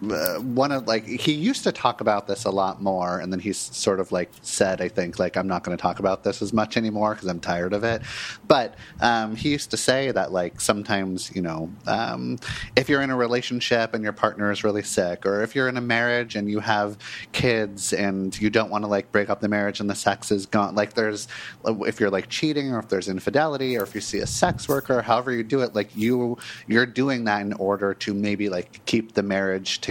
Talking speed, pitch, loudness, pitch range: 245 wpm, 105 Hz, -24 LUFS, 100-120 Hz